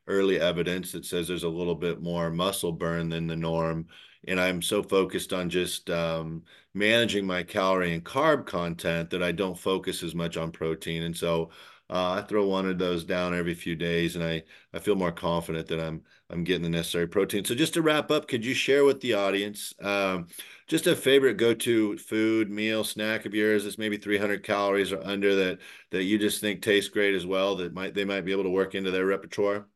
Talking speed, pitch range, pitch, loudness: 215 wpm, 85-105 Hz, 95 Hz, -27 LUFS